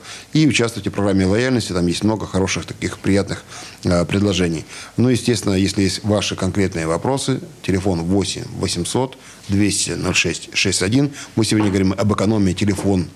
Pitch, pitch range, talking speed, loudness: 100 Hz, 95-115 Hz, 145 wpm, -19 LUFS